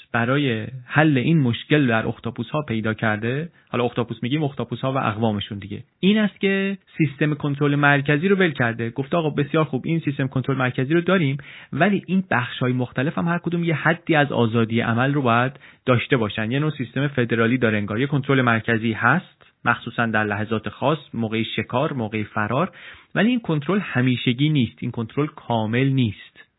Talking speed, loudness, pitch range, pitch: 180 wpm, -22 LUFS, 115-150 Hz, 130 Hz